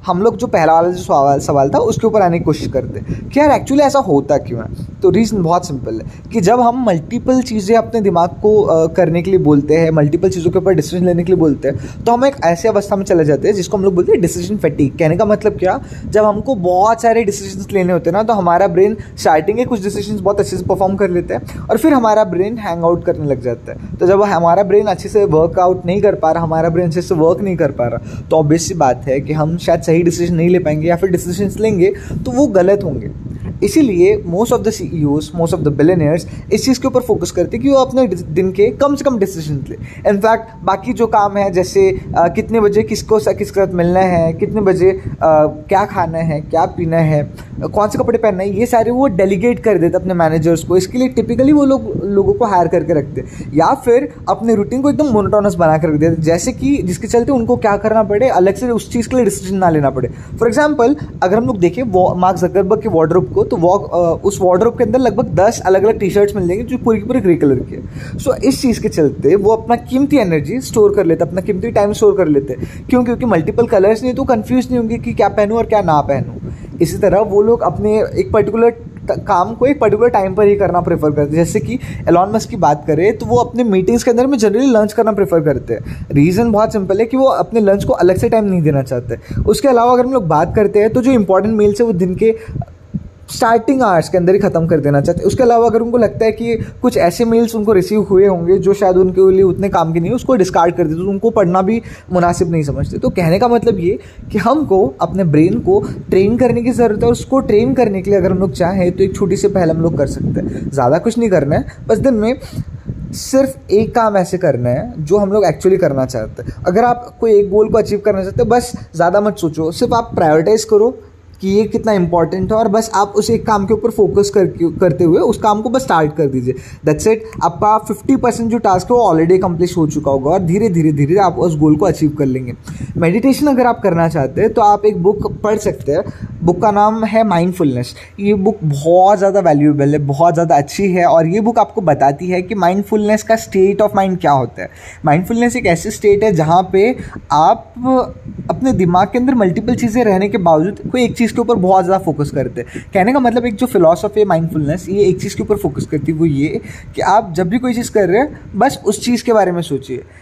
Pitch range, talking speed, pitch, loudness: 165-225 Hz, 245 wpm, 195 Hz, -13 LUFS